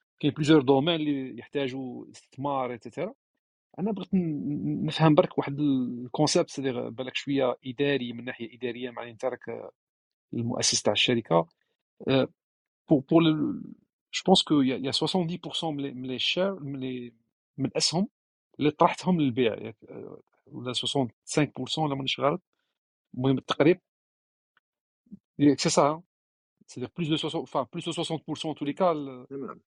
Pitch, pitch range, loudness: 140 Hz, 125-160 Hz, -27 LUFS